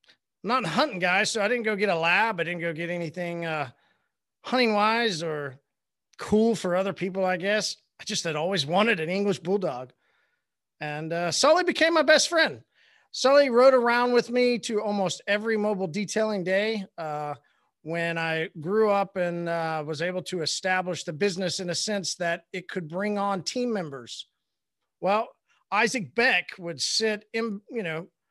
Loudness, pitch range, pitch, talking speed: -25 LUFS, 170-220 Hz, 190 Hz, 175 wpm